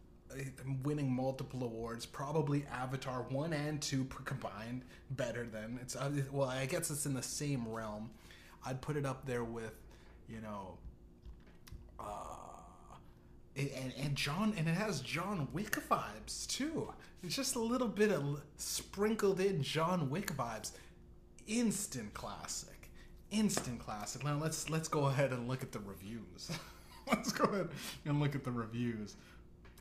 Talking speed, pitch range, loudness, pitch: 145 wpm, 115-150 Hz, -39 LUFS, 130 Hz